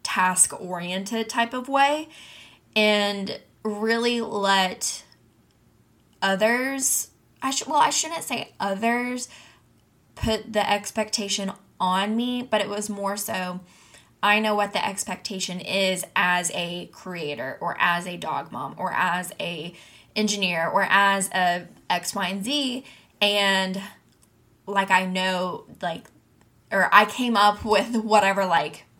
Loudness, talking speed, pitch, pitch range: -23 LUFS, 130 wpm, 200 Hz, 185-220 Hz